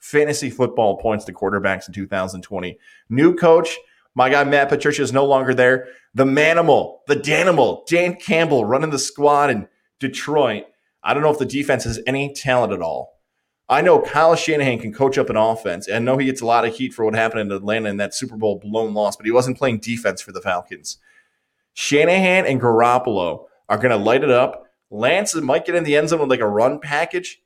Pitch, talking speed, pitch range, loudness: 130 Hz, 210 wpm, 110-150 Hz, -18 LUFS